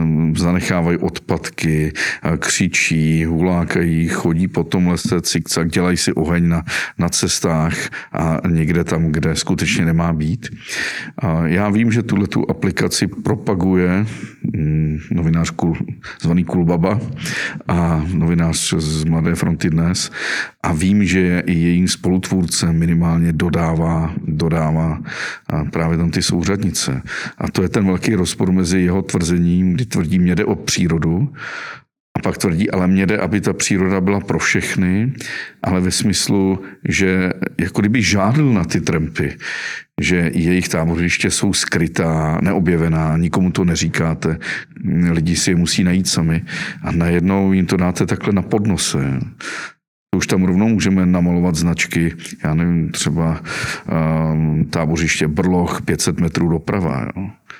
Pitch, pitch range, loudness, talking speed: 85 Hz, 80-90 Hz, -17 LUFS, 135 wpm